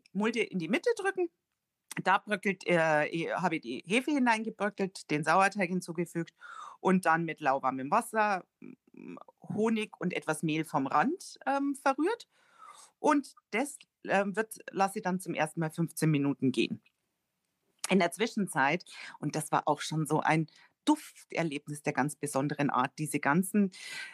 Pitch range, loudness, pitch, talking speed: 155-225 Hz, -31 LUFS, 185 Hz, 150 wpm